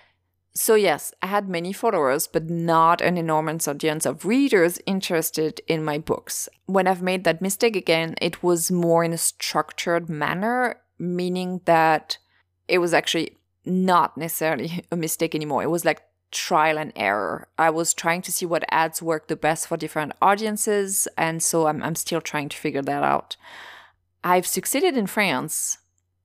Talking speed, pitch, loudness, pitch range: 165 wpm, 165 Hz, -22 LUFS, 155-180 Hz